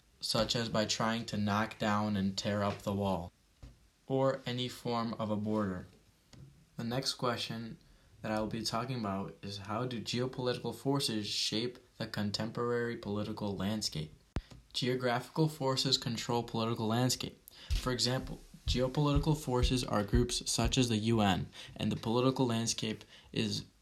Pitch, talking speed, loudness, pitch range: 115 Hz, 145 wpm, -34 LUFS, 105-125 Hz